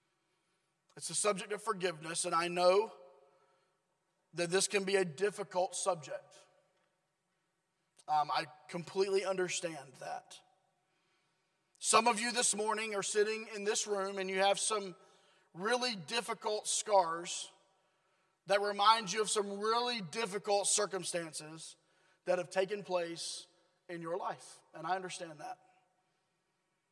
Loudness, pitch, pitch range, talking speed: -34 LUFS, 190 Hz, 185-200 Hz, 125 wpm